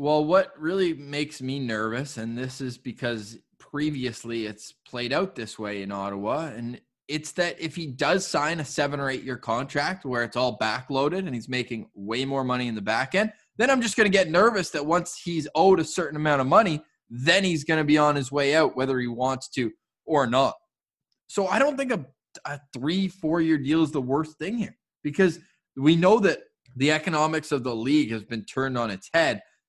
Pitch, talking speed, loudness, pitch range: 145 Hz, 210 wpm, -25 LUFS, 125-170 Hz